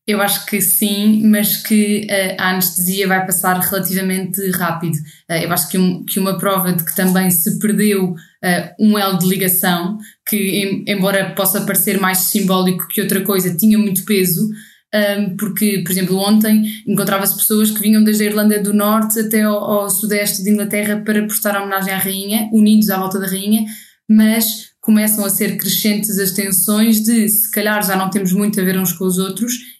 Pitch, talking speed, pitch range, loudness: 200 Hz, 190 wpm, 190-210 Hz, -15 LUFS